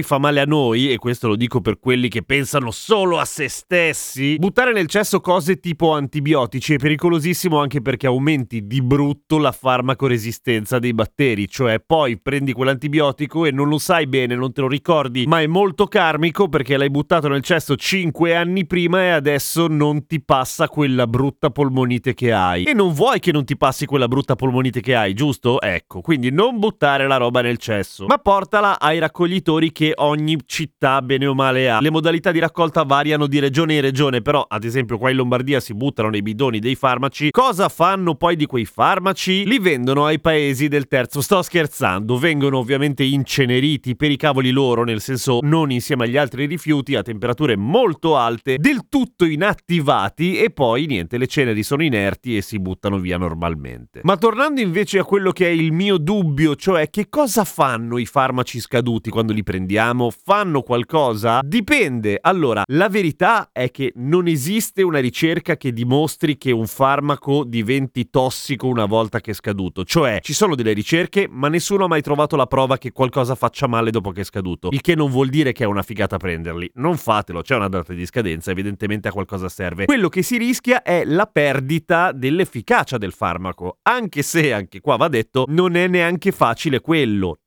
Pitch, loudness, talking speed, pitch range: 140 Hz, -18 LUFS, 190 wpm, 120-165 Hz